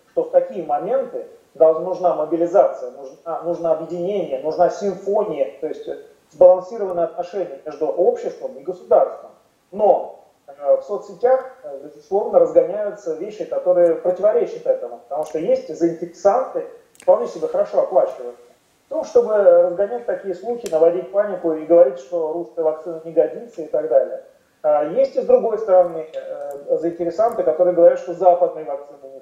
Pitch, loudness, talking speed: 190 Hz, -19 LUFS, 140 wpm